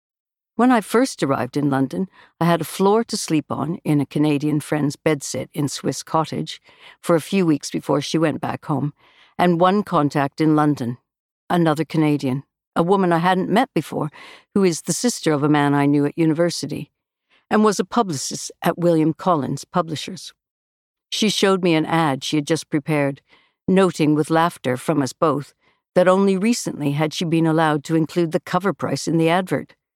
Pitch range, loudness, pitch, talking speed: 145-180 Hz, -20 LUFS, 160 Hz, 185 wpm